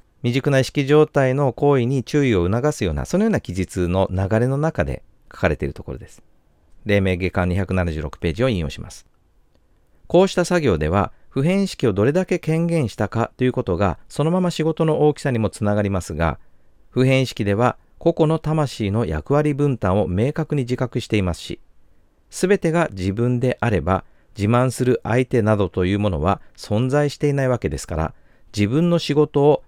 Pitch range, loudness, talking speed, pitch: 90-145 Hz, -20 LUFS, 350 characters per minute, 120 Hz